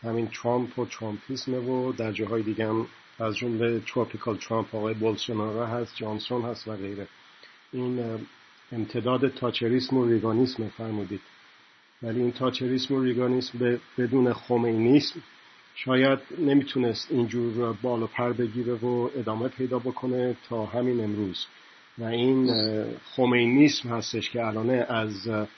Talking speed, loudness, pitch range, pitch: 125 wpm, -27 LUFS, 110-125 Hz, 120 Hz